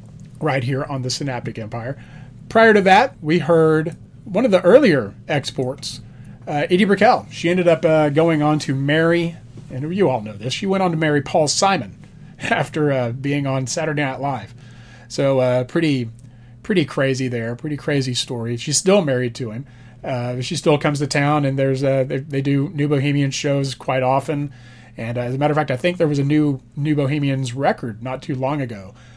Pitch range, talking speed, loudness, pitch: 125-155 Hz, 200 wpm, -19 LUFS, 140 Hz